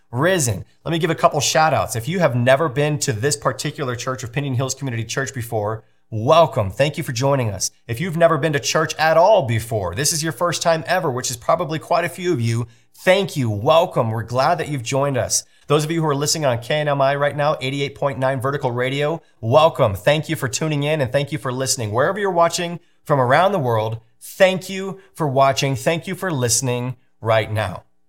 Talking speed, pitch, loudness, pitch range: 220 wpm, 140 Hz, -19 LUFS, 125-160 Hz